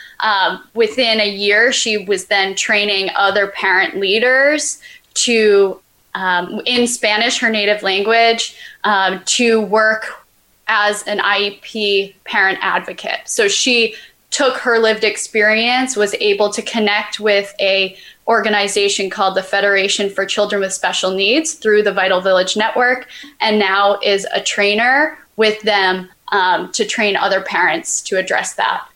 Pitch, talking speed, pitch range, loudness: 210 Hz, 140 wpm, 200-230 Hz, -15 LUFS